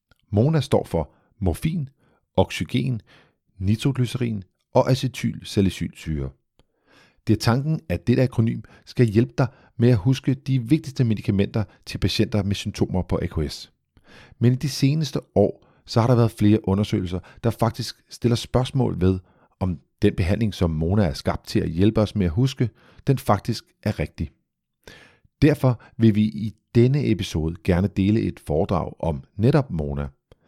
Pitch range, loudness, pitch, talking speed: 95-125 Hz, -23 LUFS, 110 Hz, 150 wpm